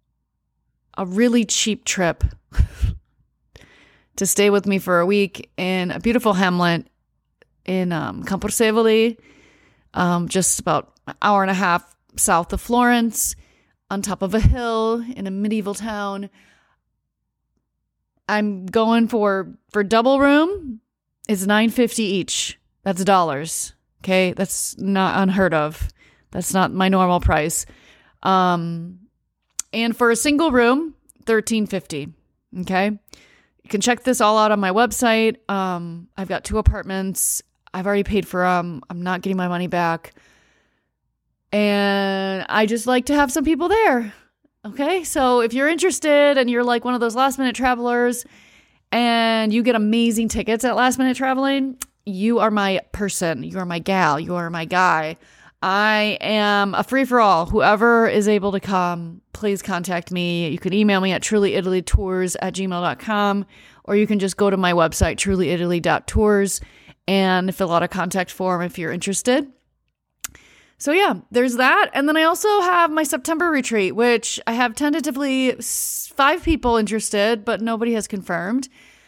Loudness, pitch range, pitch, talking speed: -19 LUFS, 185-240 Hz, 205 Hz, 150 wpm